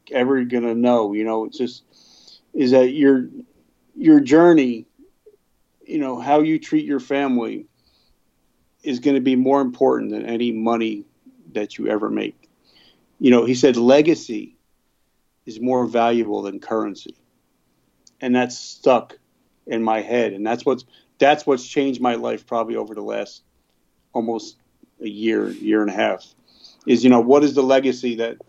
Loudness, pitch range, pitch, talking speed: -19 LUFS, 115-140 Hz, 125 Hz, 160 wpm